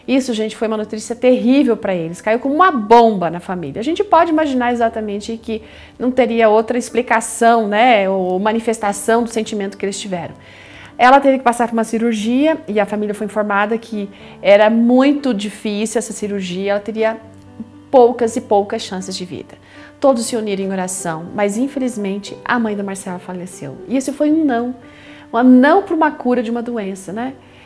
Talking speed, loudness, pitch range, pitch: 180 wpm, -16 LUFS, 200-245 Hz, 225 Hz